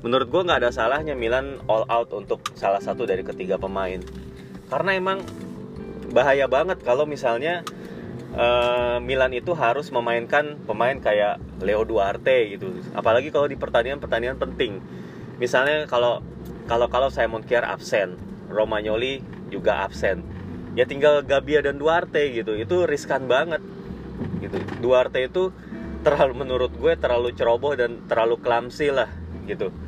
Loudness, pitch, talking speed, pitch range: -23 LUFS, 120 Hz, 135 wpm, 110-150 Hz